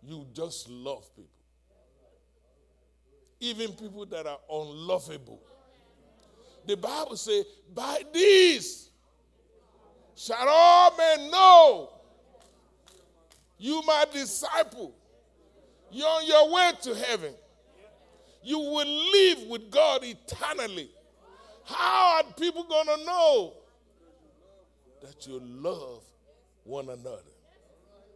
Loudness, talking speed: -23 LUFS, 95 wpm